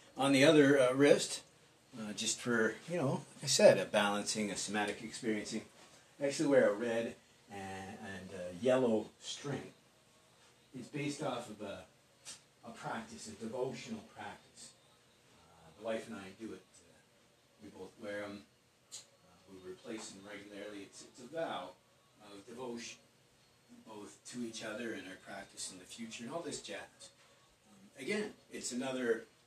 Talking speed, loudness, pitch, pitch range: 160 wpm, -35 LUFS, 110 Hz, 100-125 Hz